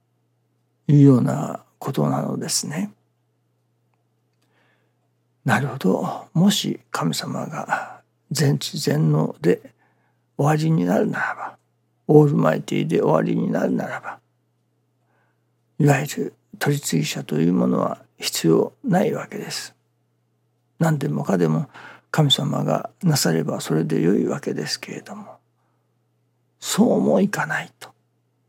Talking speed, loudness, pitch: 230 characters per minute, -21 LUFS, 80 Hz